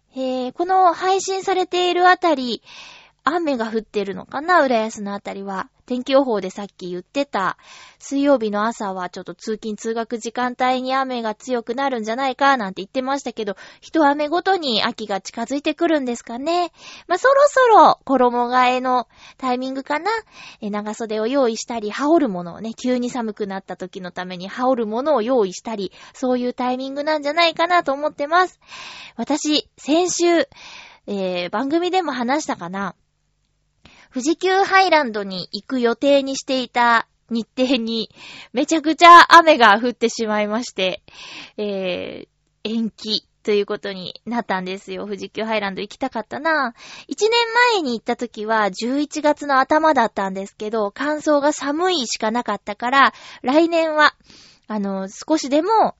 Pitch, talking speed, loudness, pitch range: 250 Hz, 330 characters per minute, -19 LUFS, 215-300 Hz